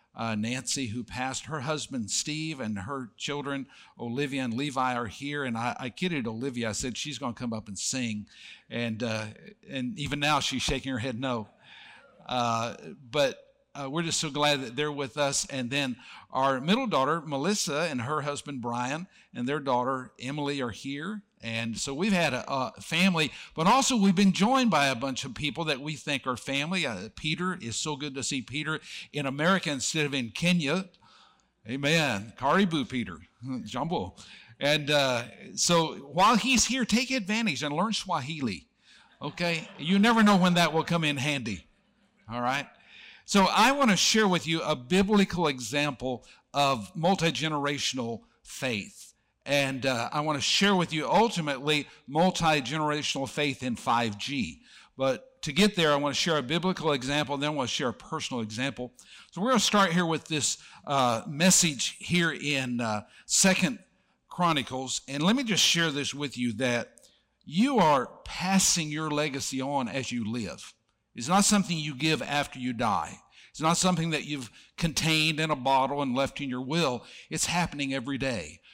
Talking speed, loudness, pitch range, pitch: 180 wpm, -27 LUFS, 130-170 Hz, 145 Hz